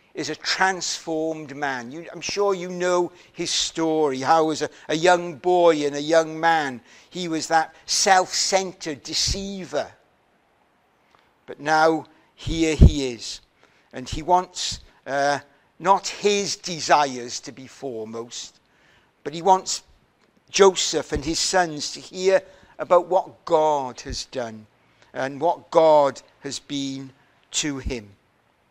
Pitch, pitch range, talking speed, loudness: 160 Hz, 140-180 Hz, 130 wpm, -22 LUFS